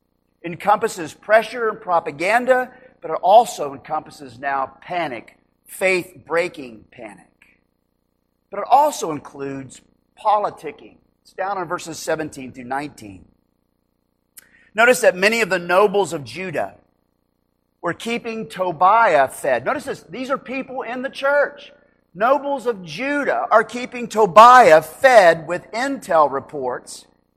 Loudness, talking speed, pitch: -18 LUFS, 120 wpm, 175 Hz